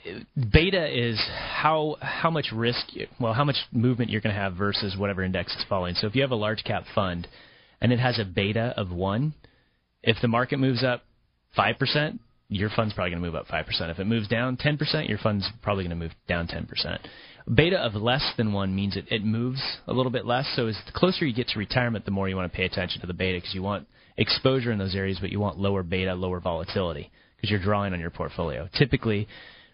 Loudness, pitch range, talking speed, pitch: -26 LUFS, 95-125 Hz, 240 wpm, 110 Hz